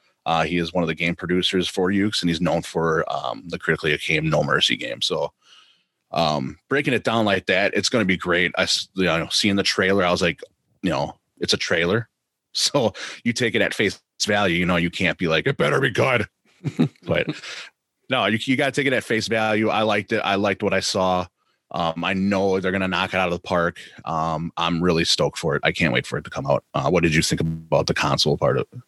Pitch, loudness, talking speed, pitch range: 95 Hz, -21 LUFS, 250 wpm, 85-100 Hz